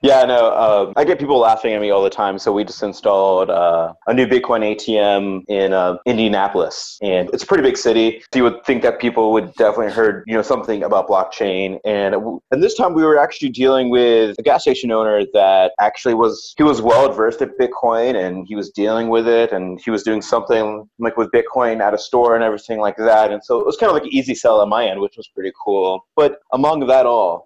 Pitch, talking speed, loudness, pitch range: 115 Hz, 240 wpm, -16 LUFS, 100-125 Hz